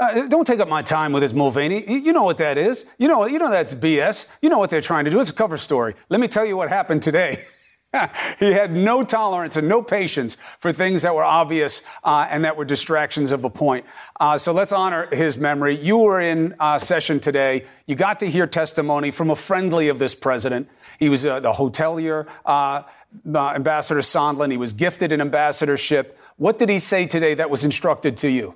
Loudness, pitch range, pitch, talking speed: -19 LUFS, 145-190 Hz, 155 Hz, 220 wpm